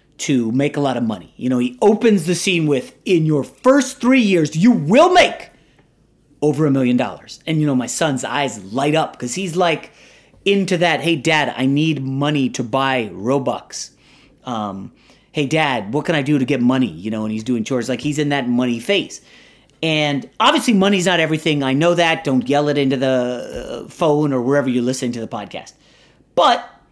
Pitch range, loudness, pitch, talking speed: 130-170 Hz, -17 LUFS, 145 Hz, 200 wpm